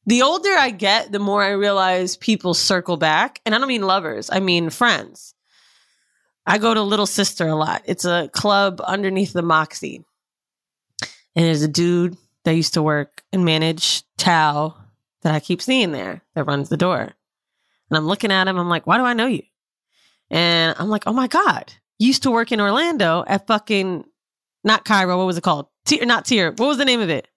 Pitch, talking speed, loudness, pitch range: 185 Hz, 205 wpm, -18 LUFS, 165-220 Hz